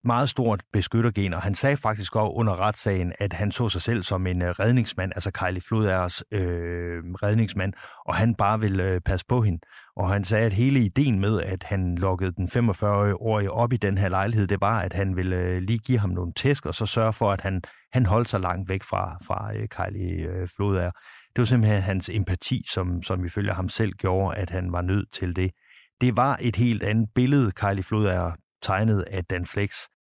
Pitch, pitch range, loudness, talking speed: 100 Hz, 95-110 Hz, -25 LUFS, 200 wpm